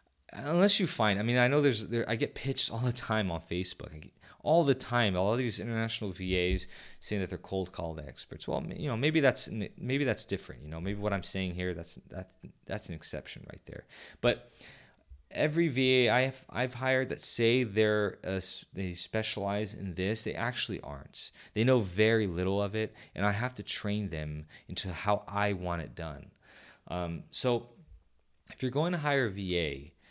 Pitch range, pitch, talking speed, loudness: 90-120 Hz, 105 Hz, 200 wpm, -31 LUFS